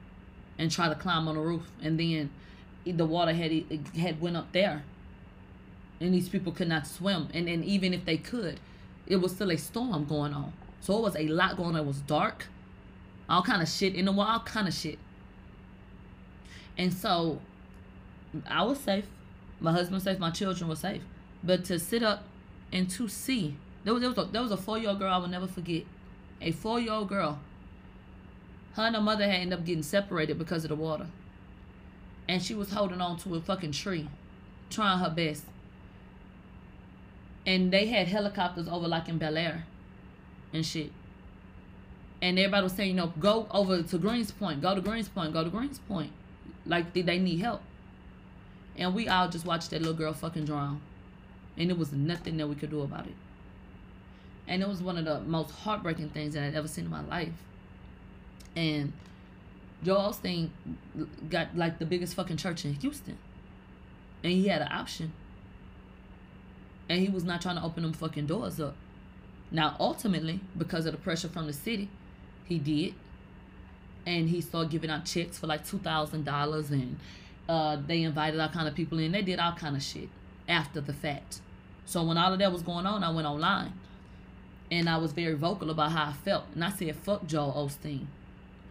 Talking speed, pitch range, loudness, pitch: 190 wpm, 140-185 Hz, -31 LUFS, 165 Hz